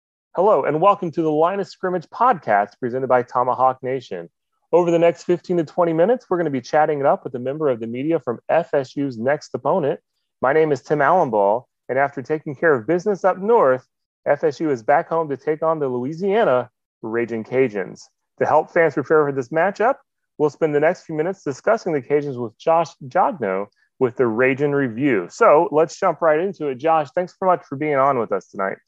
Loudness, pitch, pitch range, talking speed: -20 LUFS, 155 Hz, 130-170 Hz, 210 wpm